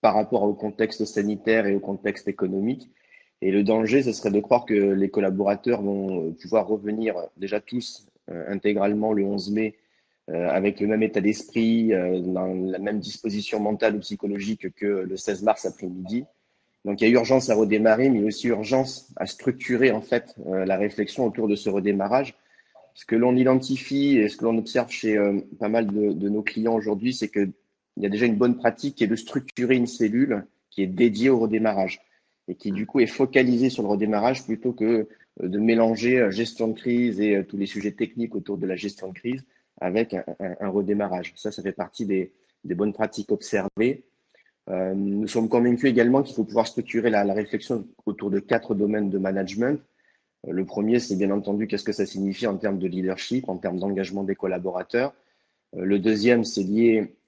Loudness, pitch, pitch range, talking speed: -24 LUFS, 105 Hz, 100-115 Hz, 200 wpm